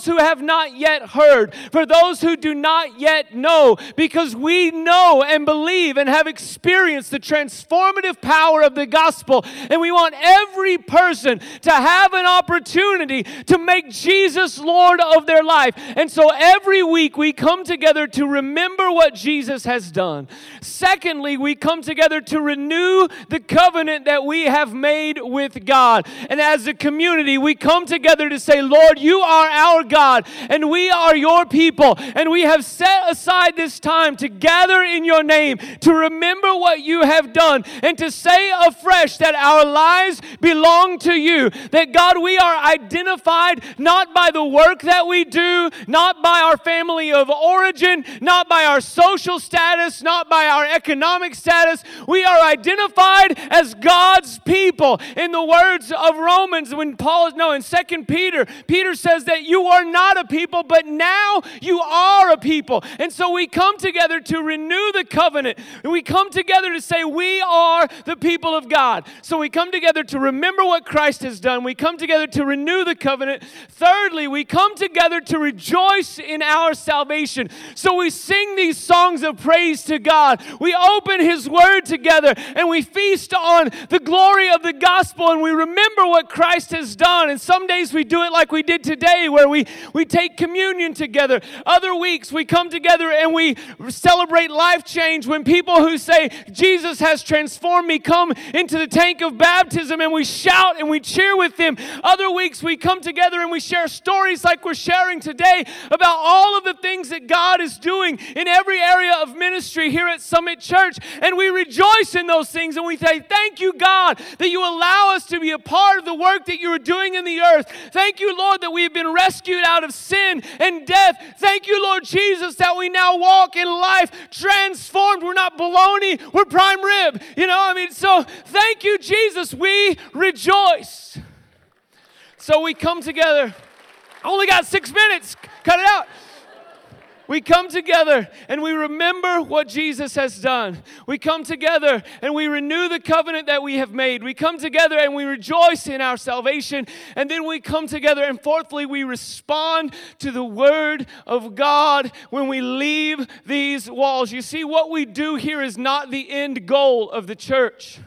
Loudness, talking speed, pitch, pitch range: -15 LUFS, 180 wpm, 330 Hz, 300-360 Hz